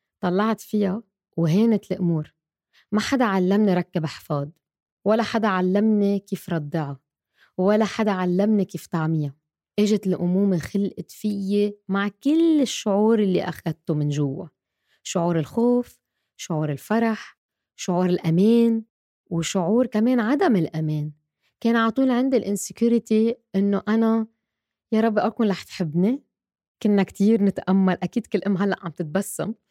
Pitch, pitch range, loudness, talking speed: 200 Hz, 175-220 Hz, -23 LUFS, 120 wpm